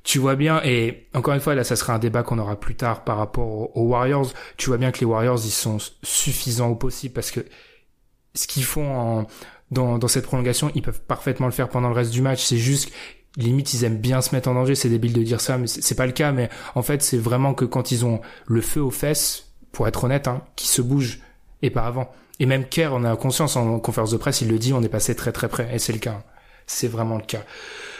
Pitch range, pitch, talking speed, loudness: 115-135 Hz, 125 Hz, 260 wpm, -22 LUFS